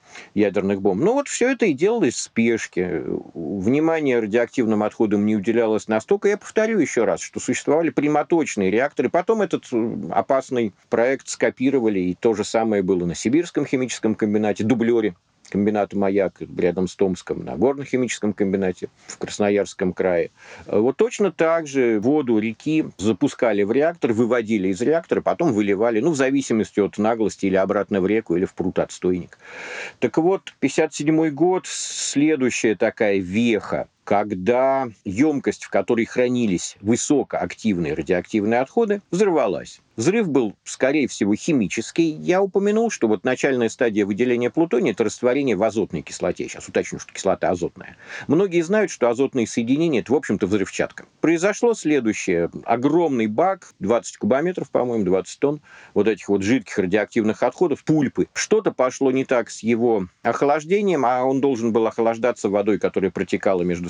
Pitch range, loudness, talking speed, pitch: 105-155 Hz, -21 LUFS, 150 wpm, 120 Hz